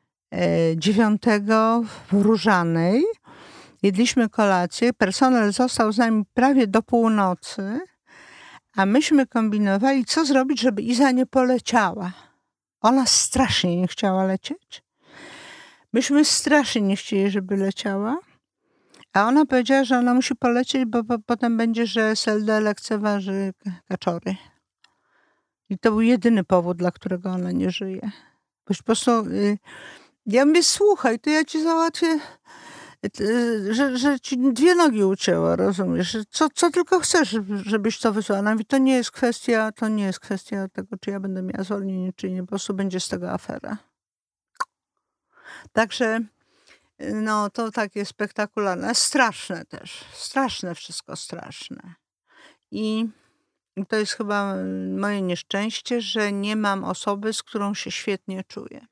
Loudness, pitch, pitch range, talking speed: -22 LUFS, 220 Hz, 200-255 Hz, 130 wpm